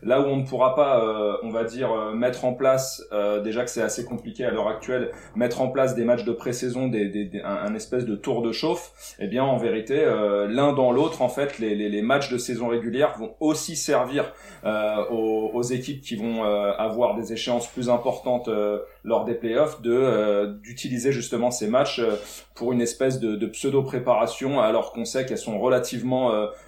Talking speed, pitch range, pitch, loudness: 215 wpm, 110-130 Hz, 120 Hz, -24 LUFS